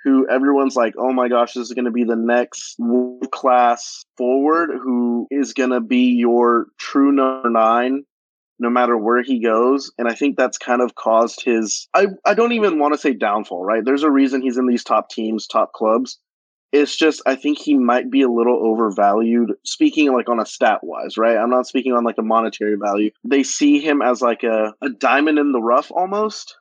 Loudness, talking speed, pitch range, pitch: -17 LUFS, 210 wpm, 120-140 Hz, 125 Hz